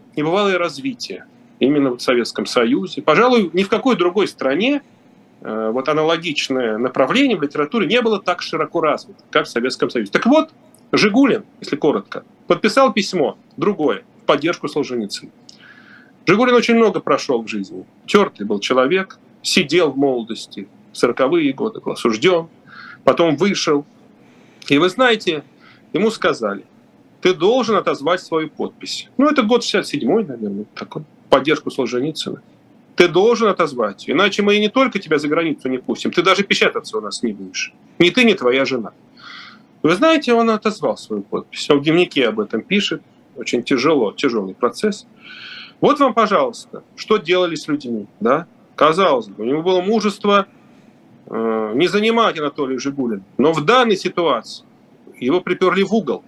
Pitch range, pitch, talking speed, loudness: 150-230 Hz, 190 Hz, 150 wpm, -17 LUFS